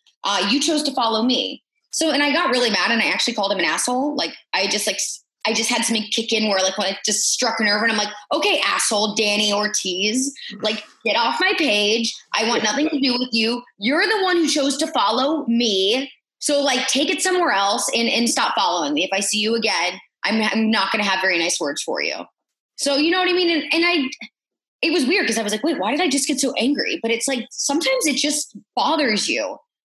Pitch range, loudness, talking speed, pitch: 215-290 Hz, -19 LUFS, 245 wpm, 250 Hz